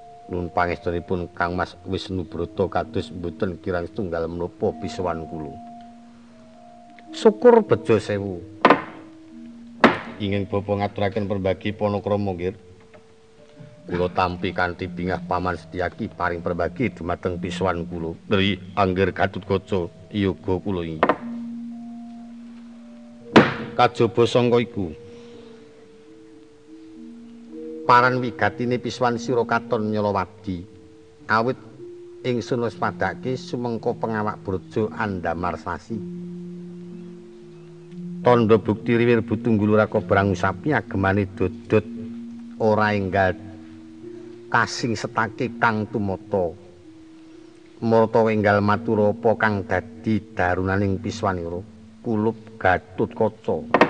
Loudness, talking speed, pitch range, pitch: -23 LUFS, 95 wpm, 95-125 Hz, 110 Hz